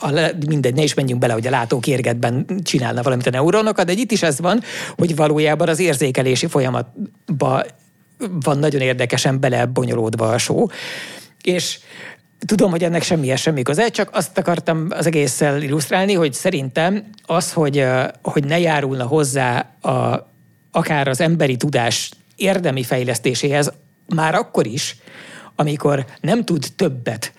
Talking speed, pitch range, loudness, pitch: 145 wpm, 135-175 Hz, -18 LUFS, 150 Hz